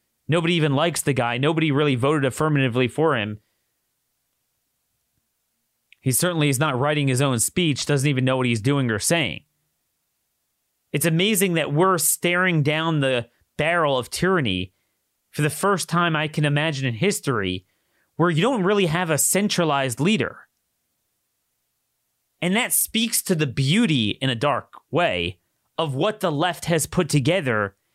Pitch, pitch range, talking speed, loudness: 150 Hz, 130-170 Hz, 150 wpm, -21 LUFS